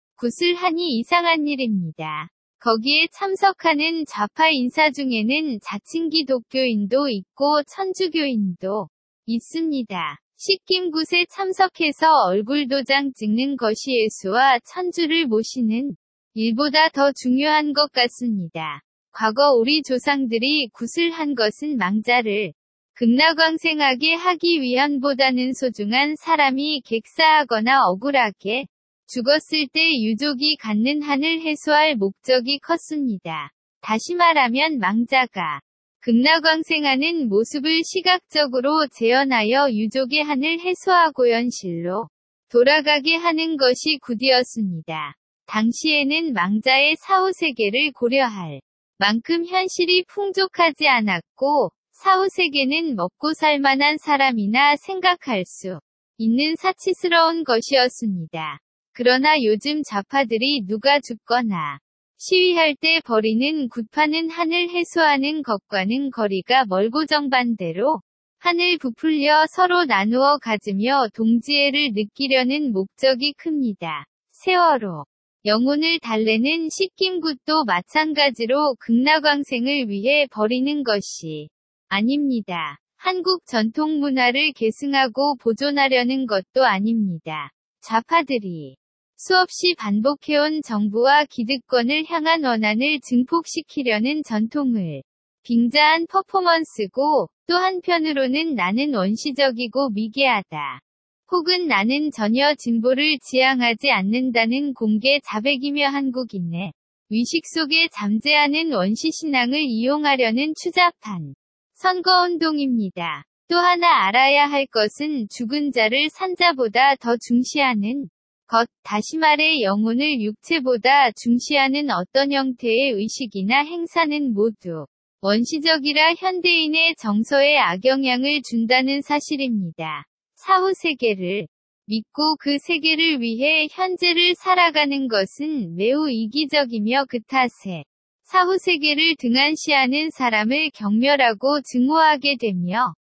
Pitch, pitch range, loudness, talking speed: 275 Hz, 230-310 Hz, -19 LUFS, 260 characters per minute